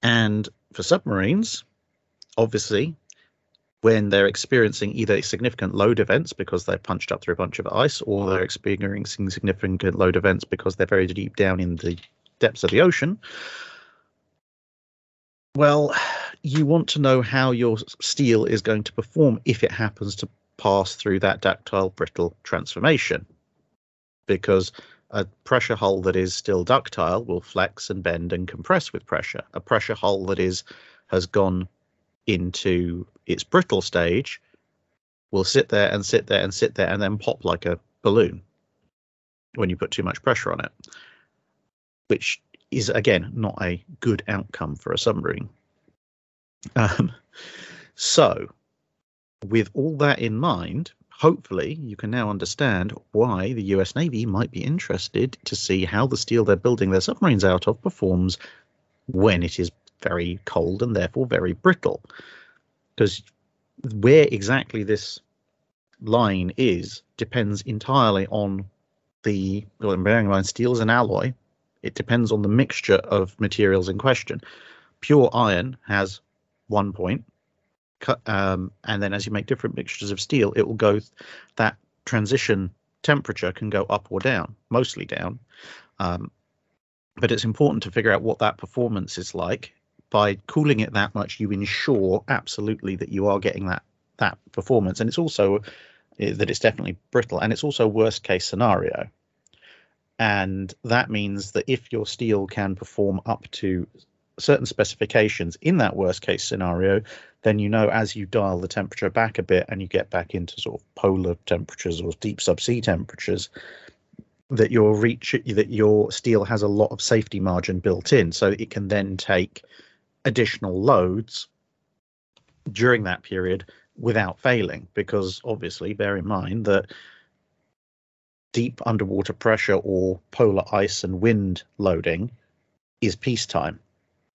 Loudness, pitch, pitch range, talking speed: -23 LUFS, 105 Hz, 95-115 Hz, 155 wpm